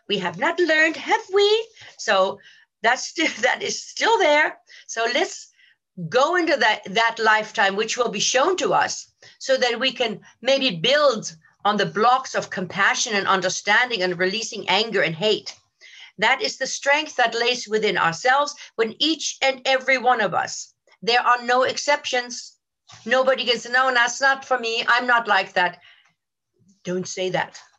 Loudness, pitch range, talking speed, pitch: -20 LUFS, 200-270 Hz, 170 wpm, 240 Hz